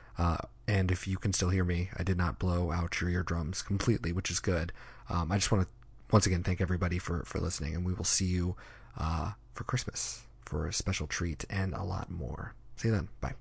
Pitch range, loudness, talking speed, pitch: 90-105 Hz, -32 LUFS, 230 wpm, 95 Hz